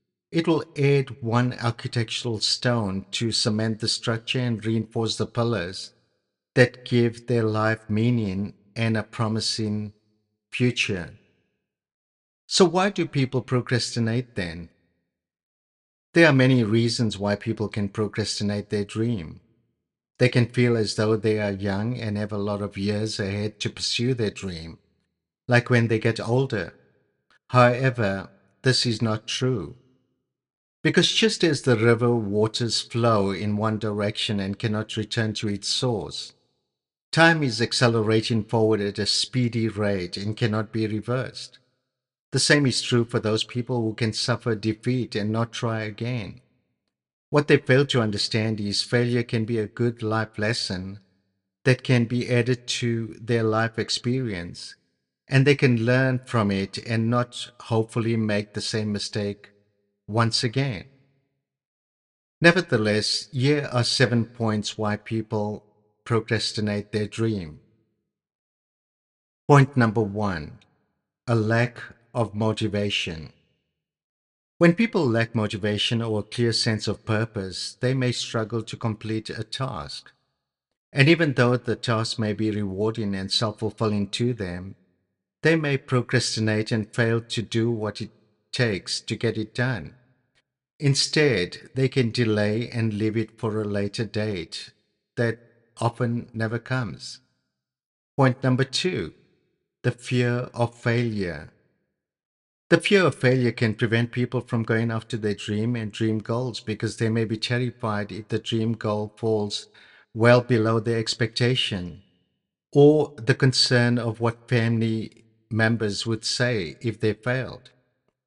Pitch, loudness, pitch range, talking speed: 115 Hz, -24 LUFS, 105-125 Hz, 135 wpm